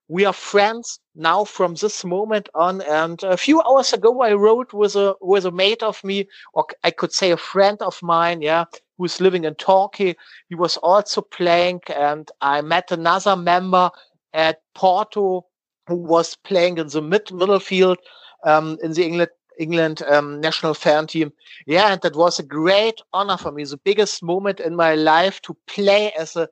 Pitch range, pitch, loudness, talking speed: 165-200 Hz, 180 Hz, -19 LUFS, 190 wpm